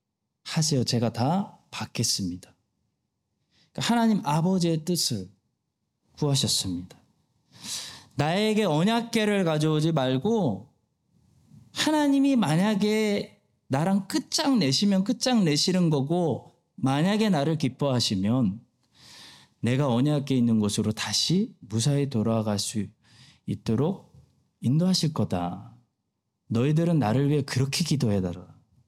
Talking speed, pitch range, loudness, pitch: 240 characters per minute, 115-185 Hz, -25 LUFS, 145 Hz